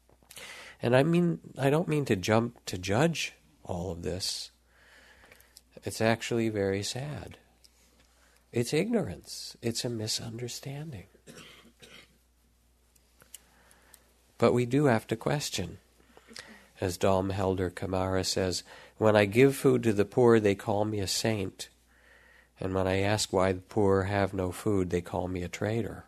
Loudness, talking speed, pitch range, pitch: -29 LUFS, 140 wpm, 85-115 Hz, 95 Hz